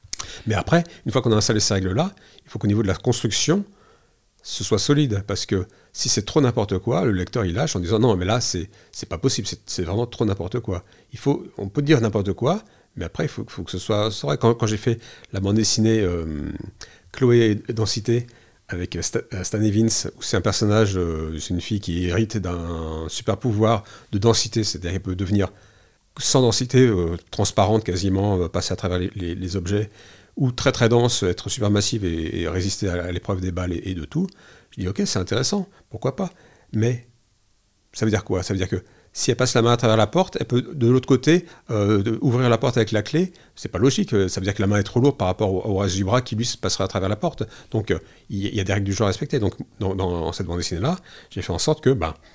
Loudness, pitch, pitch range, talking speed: -22 LUFS, 105 Hz, 95-120 Hz, 245 wpm